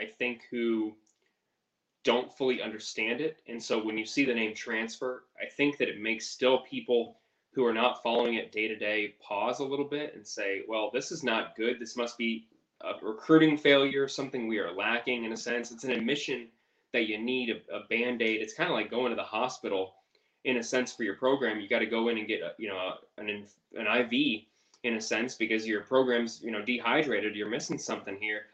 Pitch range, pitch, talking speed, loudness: 110-125 Hz, 115 Hz, 220 wpm, -30 LUFS